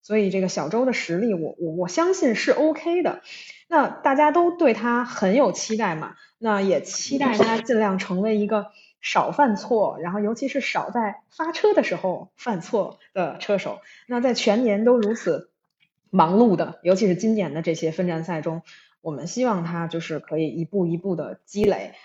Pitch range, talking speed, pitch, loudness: 175-245 Hz, 270 characters per minute, 210 Hz, -23 LUFS